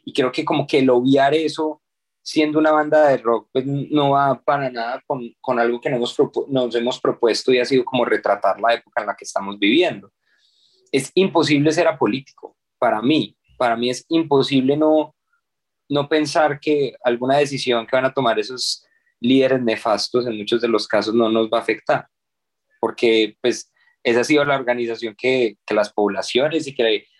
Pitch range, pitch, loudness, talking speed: 120-155 Hz, 135 Hz, -19 LUFS, 190 wpm